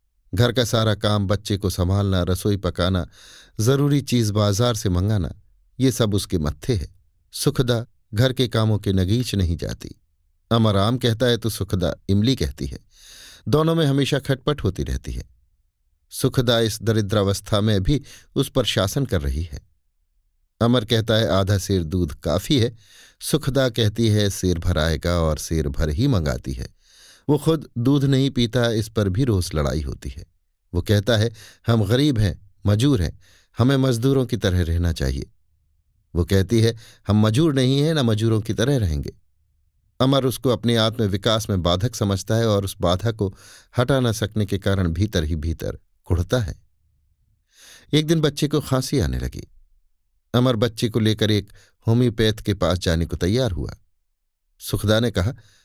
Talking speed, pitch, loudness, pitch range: 165 wpm, 105 Hz, -21 LUFS, 85-120 Hz